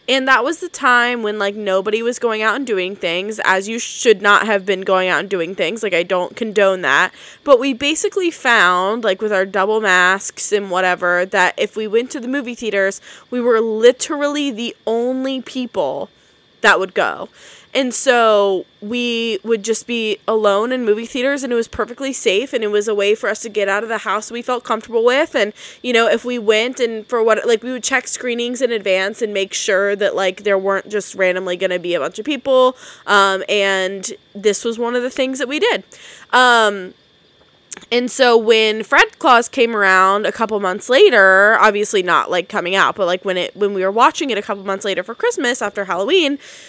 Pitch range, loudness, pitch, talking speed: 200-245 Hz, -16 LUFS, 220 Hz, 215 wpm